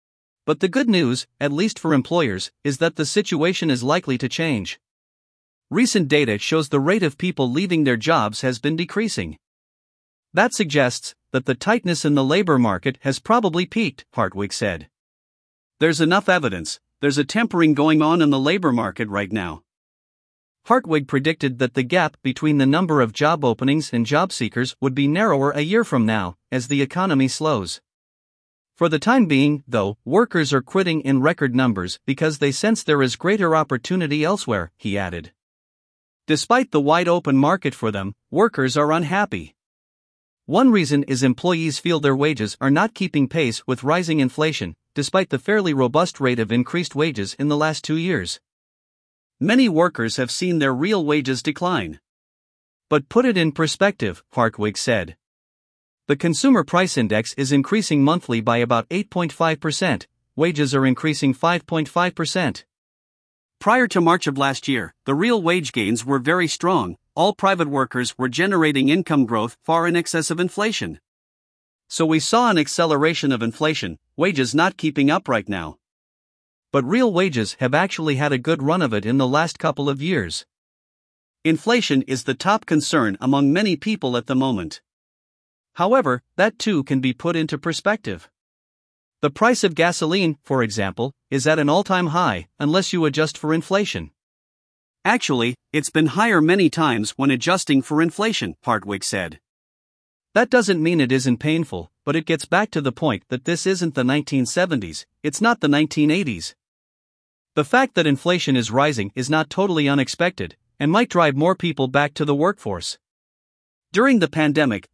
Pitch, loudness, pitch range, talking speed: 150 Hz, -20 LUFS, 130-175 Hz, 165 wpm